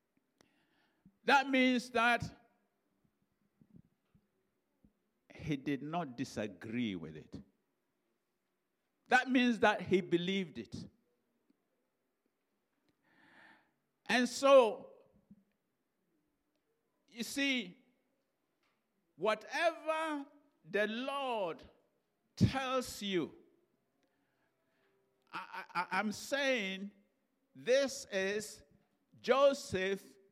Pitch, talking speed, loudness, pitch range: 235 Hz, 60 wpm, -34 LUFS, 190-270 Hz